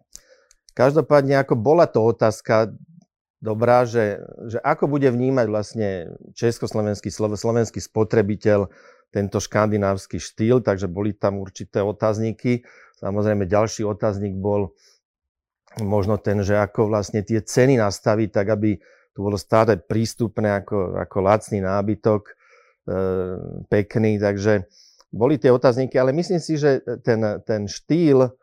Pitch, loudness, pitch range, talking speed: 110 Hz, -21 LUFS, 100-120 Hz, 120 wpm